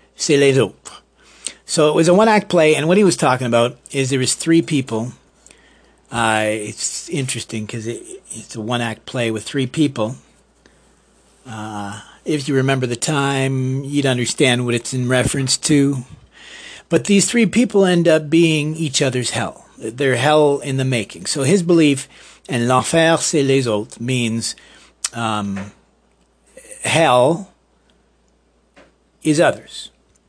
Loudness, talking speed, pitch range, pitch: -17 LUFS, 145 wpm, 120-160 Hz, 135 Hz